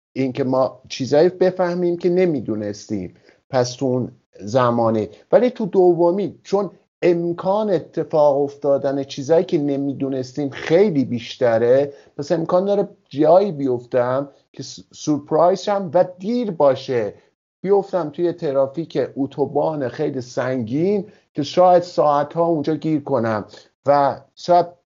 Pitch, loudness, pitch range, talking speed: 150 Hz, -19 LUFS, 135-180 Hz, 115 wpm